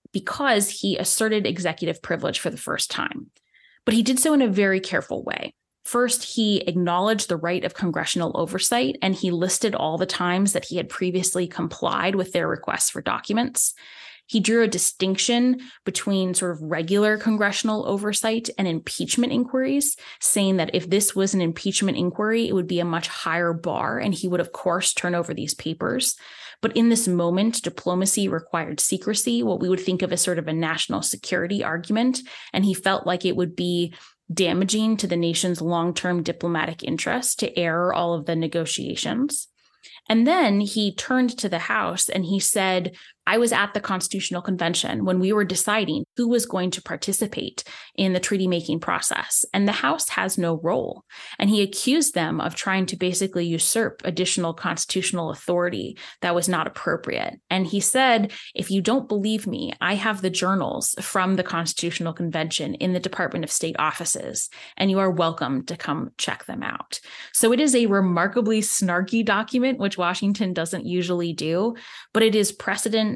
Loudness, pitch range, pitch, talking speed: -23 LUFS, 175-220 Hz, 190 Hz, 180 wpm